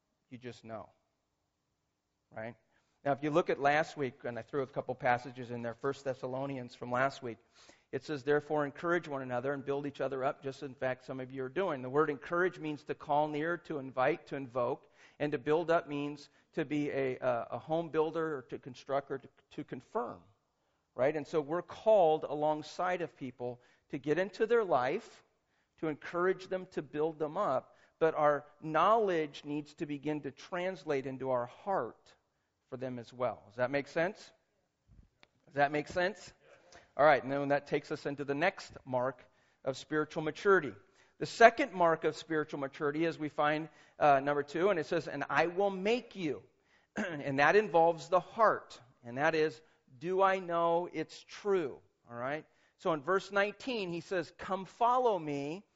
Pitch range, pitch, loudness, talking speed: 135-170 Hz, 150 Hz, -34 LUFS, 185 wpm